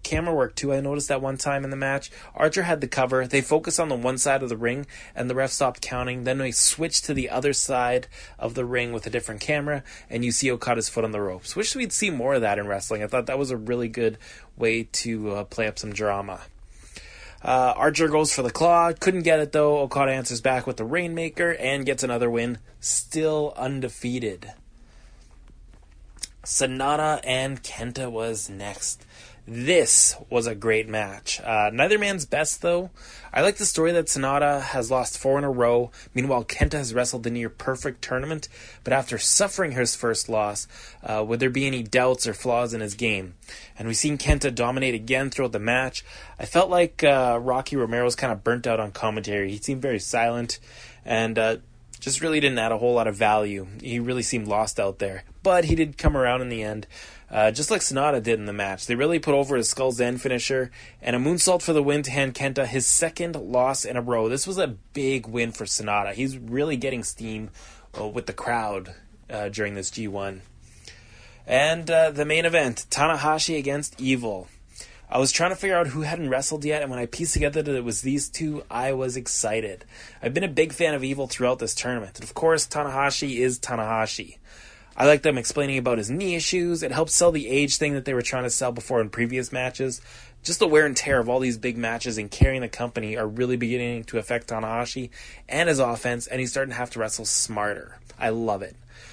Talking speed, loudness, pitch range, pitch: 215 wpm, -24 LUFS, 115-145 Hz, 125 Hz